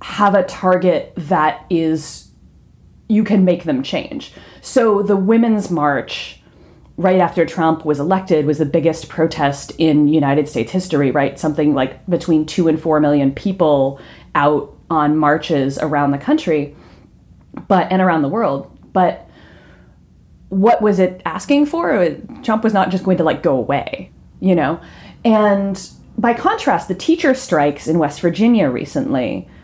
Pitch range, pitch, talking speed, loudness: 150-200 Hz, 170 Hz, 150 wpm, -16 LUFS